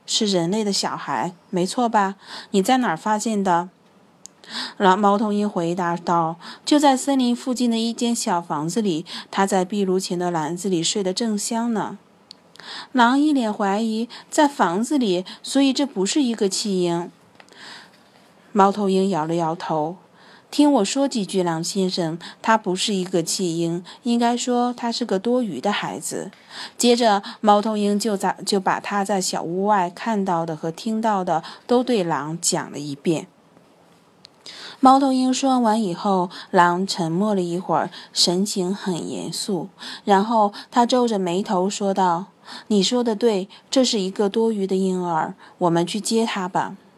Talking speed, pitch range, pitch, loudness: 225 characters per minute, 180-230 Hz, 200 Hz, -21 LUFS